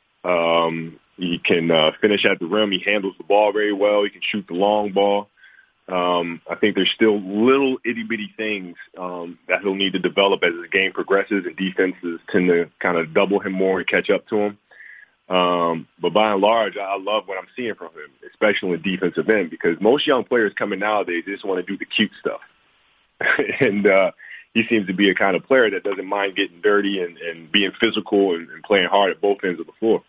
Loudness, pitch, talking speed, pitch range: -20 LUFS, 100 Hz, 225 wpm, 90-105 Hz